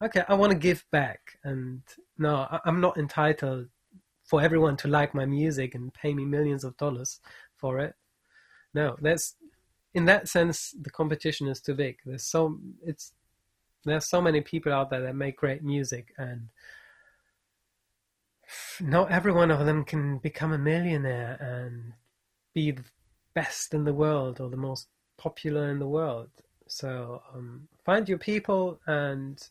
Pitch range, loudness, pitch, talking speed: 130-160 Hz, -28 LUFS, 145 Hz, 160 wpm